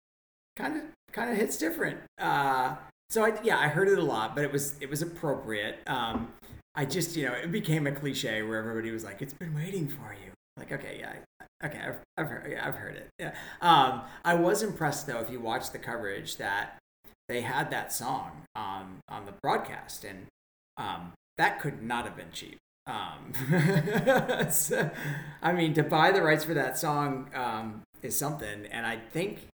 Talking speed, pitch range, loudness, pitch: 195 wpm, 115-165 Hz, -30 LUFS, 145 Hz